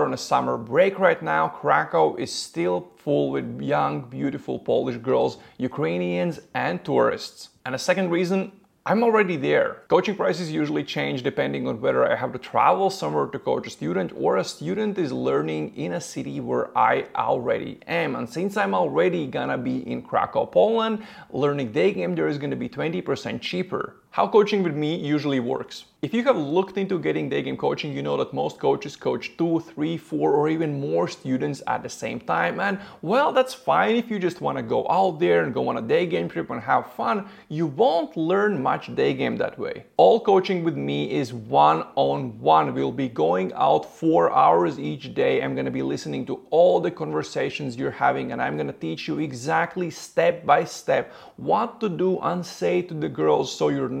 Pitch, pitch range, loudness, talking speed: 165 Hz, 115-195 Hz, -23 LUFS, 200 wpm